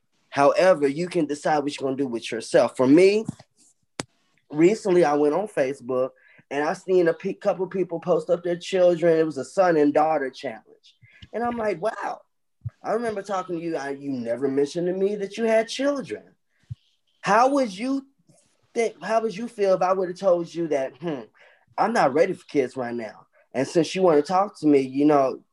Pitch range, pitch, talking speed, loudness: 145-200 Hz, 175 Hz, 205 wpm, -23 LUFS